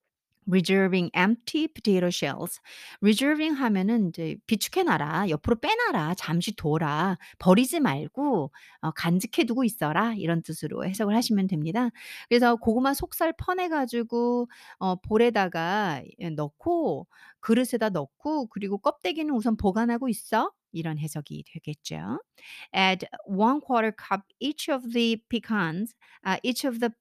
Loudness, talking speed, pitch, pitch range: -26 LUFS, 385 characters per minute, 220 Hz, 180-250 Hz